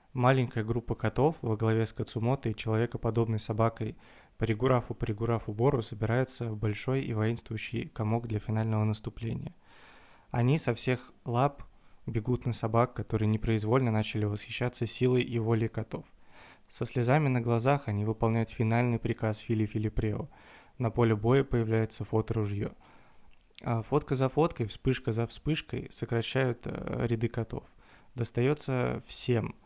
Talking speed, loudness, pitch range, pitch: 125 wpm, -31 LUFS, 110-125 Hz, 115 Hz